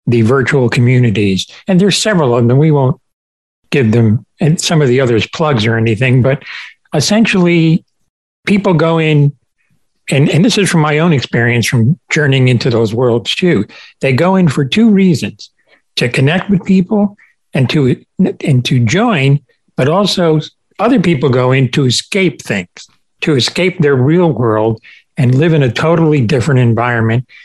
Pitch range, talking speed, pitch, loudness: 120-170 Hz, 165 wpm, 145 Hz, -11 LUFS